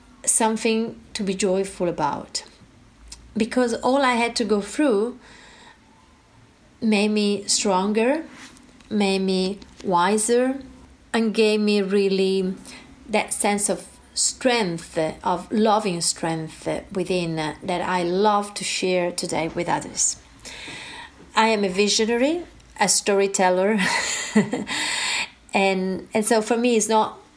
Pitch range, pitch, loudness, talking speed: 190-235 Hz, 210 Hz, -22 LUFS, 115 wpm